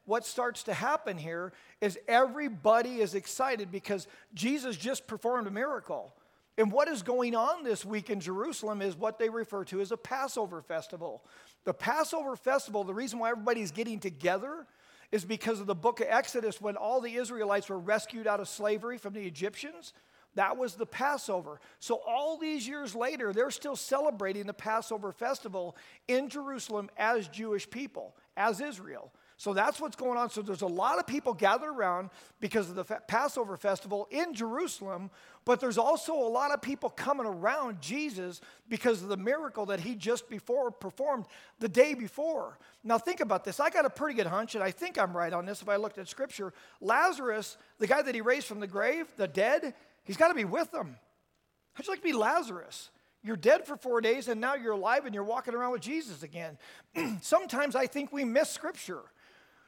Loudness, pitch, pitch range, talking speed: -32 LUFS, 230 Hz, 205-275 Hz, 195 wpm